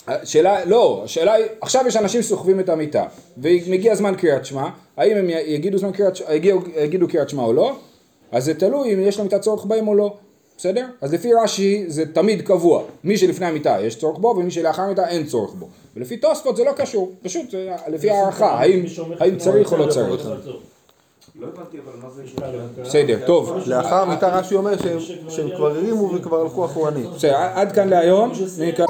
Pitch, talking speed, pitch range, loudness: 185 Hz, 165 wpm, 165-205 Hz, -19 LUFS